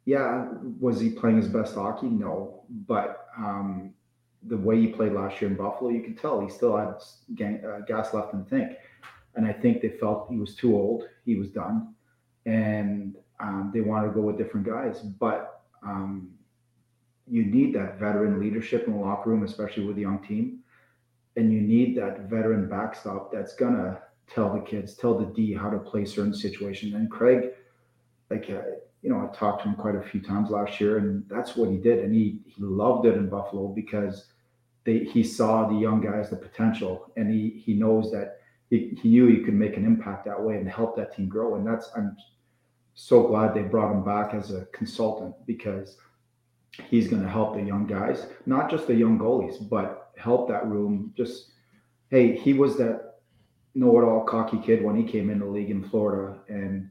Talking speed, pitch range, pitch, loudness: 200 wpm, 105-120 Hz, 110 Hz, -26 LUFS